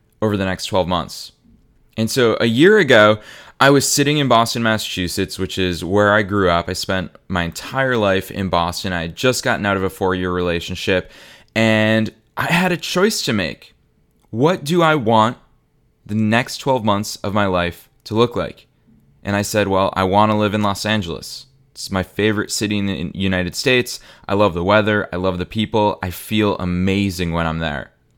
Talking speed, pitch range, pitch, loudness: 200 wpm, 95-115 Hz, 105 Hz, -18 LUFS